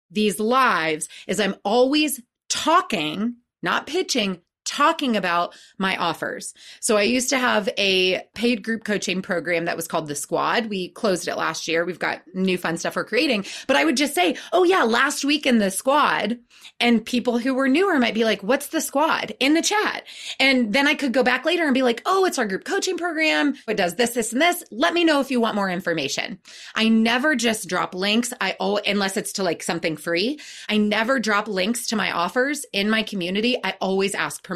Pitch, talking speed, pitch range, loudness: 230 Hz, 210 wpm, 190-270 Hz, -21 LUFS